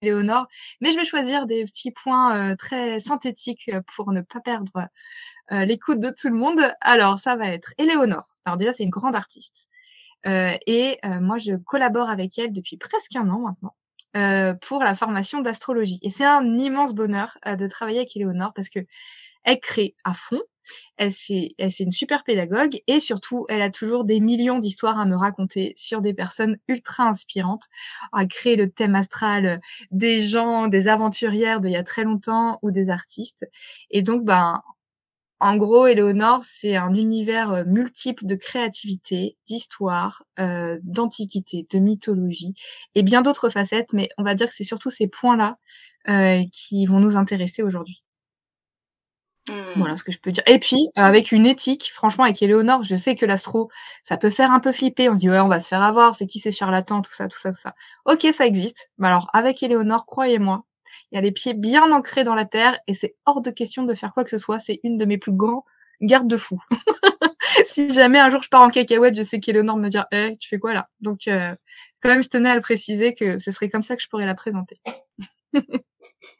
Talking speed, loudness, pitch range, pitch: 205 wpm, -20 LUFS, 195-250 Hz, 220 Hz